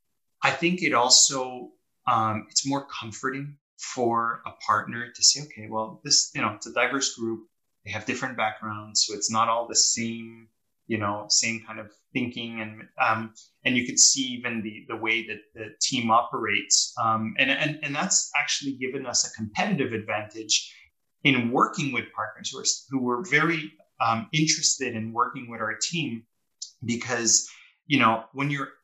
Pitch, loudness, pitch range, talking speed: 115 Hz, -24 LUFS, 110-140 Hz, 170 wpm